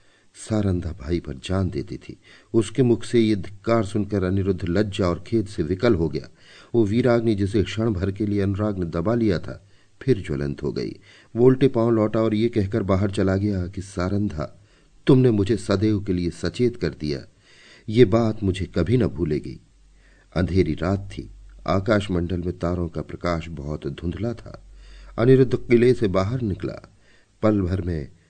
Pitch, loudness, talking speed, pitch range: 100 Hz, -23 LUFS, 170 wpm, 90-115 Hz